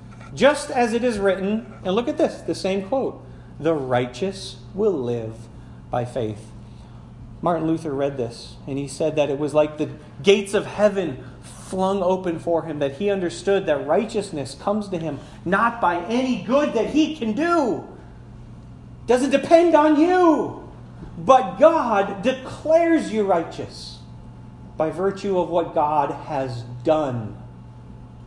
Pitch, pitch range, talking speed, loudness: 180 Hz, 140-230 Hz, 150 wpm, -21 LUFS